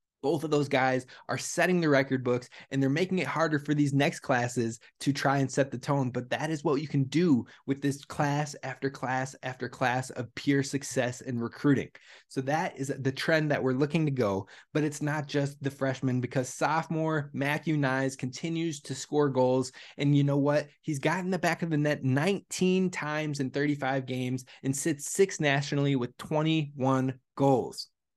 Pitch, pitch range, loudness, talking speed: 140 Hz, 130-150 Hz, -29 LUFS, 190 wpm